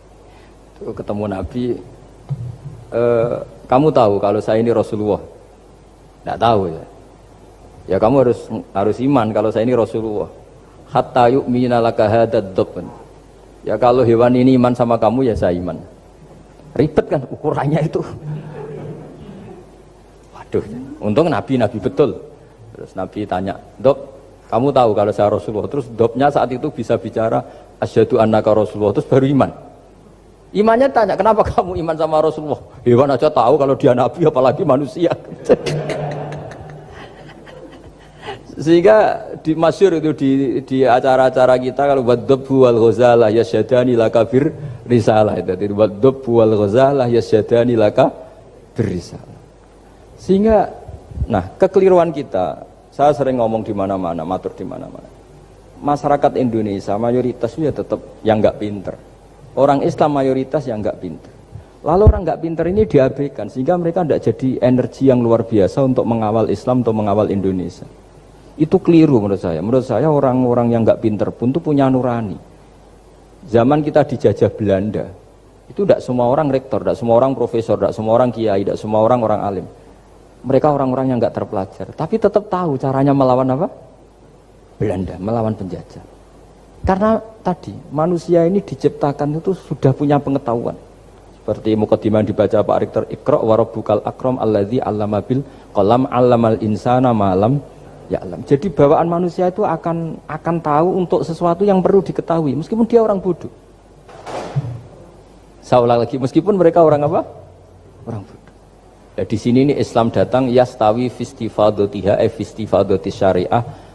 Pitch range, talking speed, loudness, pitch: 110-145 Hz, 130 wpm, -16 LUFS, 125 Hz